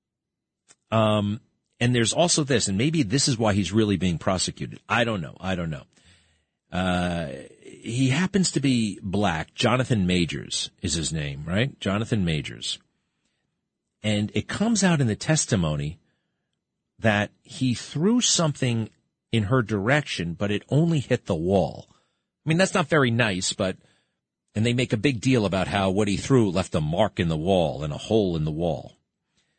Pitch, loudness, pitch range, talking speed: 110 Hz, -24 LUFS, 95-135 Hz, 180 wpm